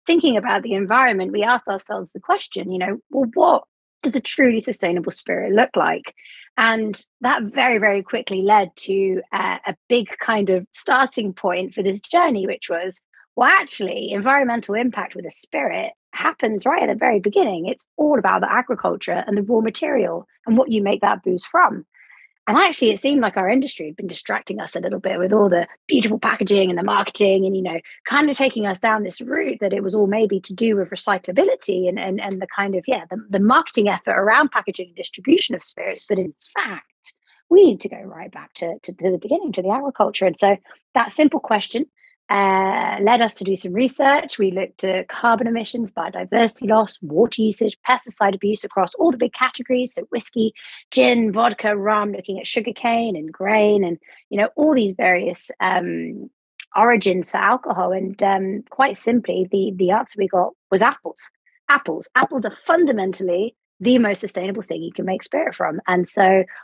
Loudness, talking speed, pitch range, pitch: -19 LUFS, 195 wpm, 190-250 Hz, 210 Hz